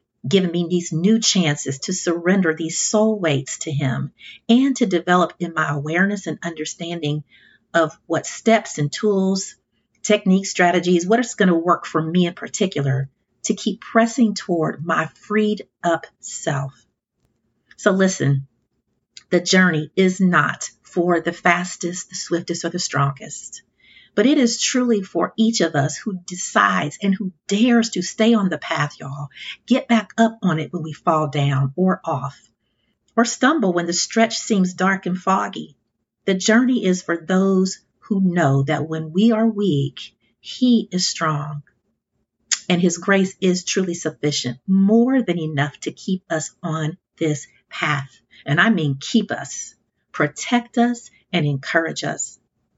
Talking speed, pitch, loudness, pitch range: 155 wpm, 180 Hz, -20 LUFS, 155-205 Hz